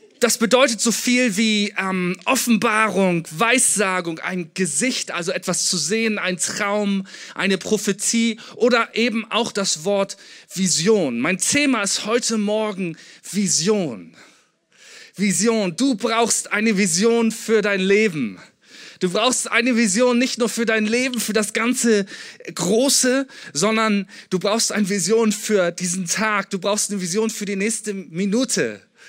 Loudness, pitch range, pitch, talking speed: -19 LUFS, 195-230 Hz, 215 Hz, 140 wpm